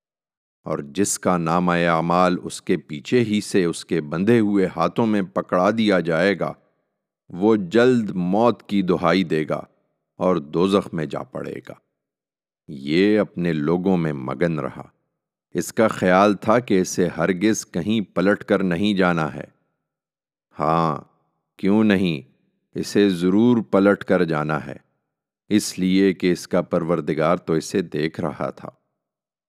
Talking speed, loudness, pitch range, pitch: 145 wpm, -21 LUFS, 80-100 Hz, 90 Hz